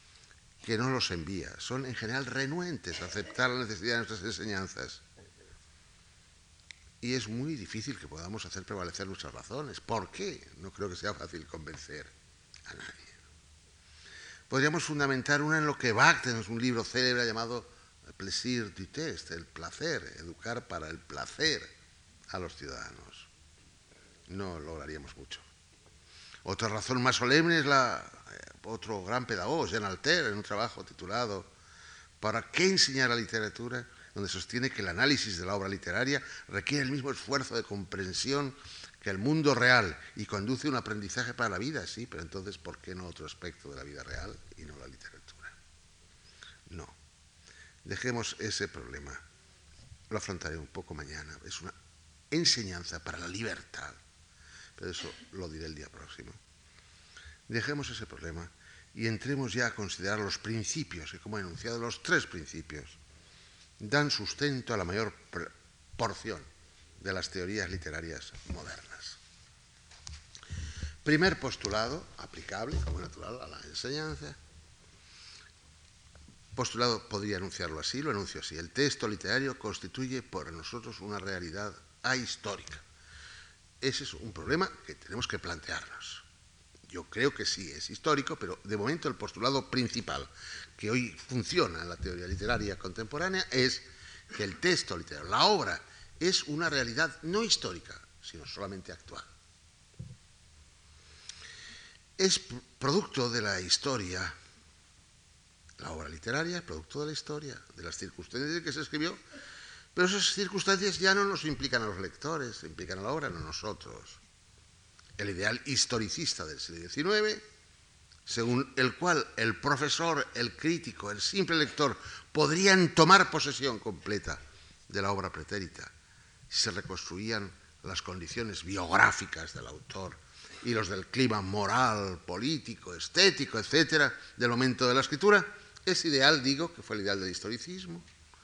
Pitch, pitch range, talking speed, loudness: 100 Hz, 85-130 Hz, 145 wpm, -32 LUFS